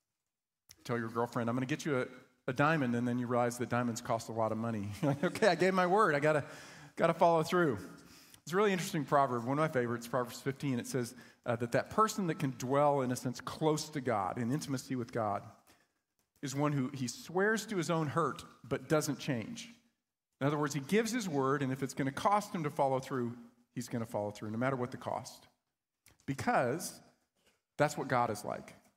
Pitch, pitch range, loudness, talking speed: 135 Hz, 120-155 Hz, -34 LUFS, 225 wpm